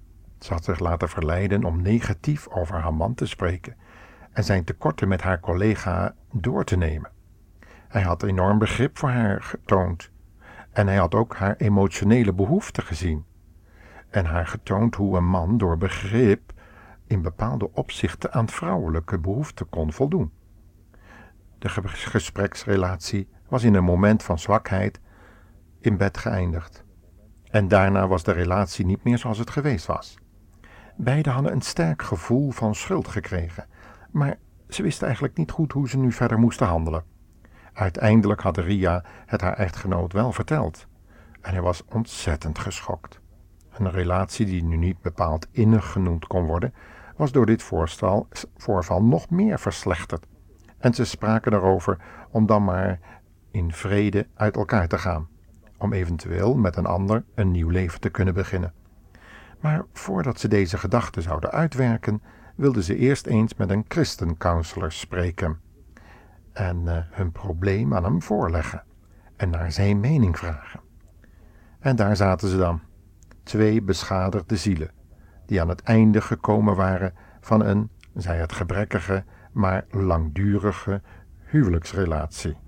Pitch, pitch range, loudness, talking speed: 95 Hz, 85-110 Hz, -24 LUFS, 145 wpm